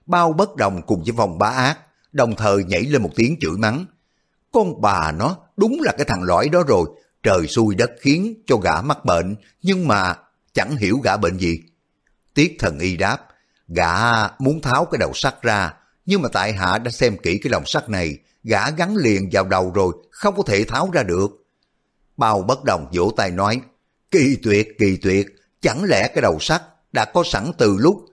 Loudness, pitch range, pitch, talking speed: -19 LUFS, 100-150 Hz, 115 Hz, 205 wpm